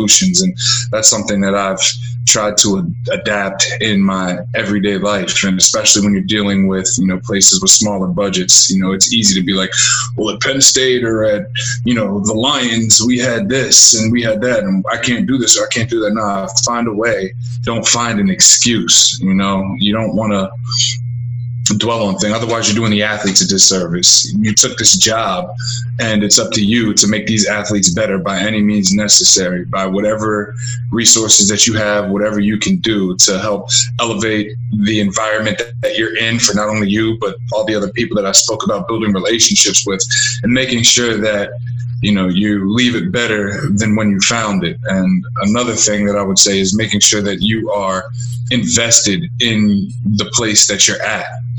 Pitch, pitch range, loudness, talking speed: 110 Hz, 100-120 Hz, -12 LUFS, 200 wpm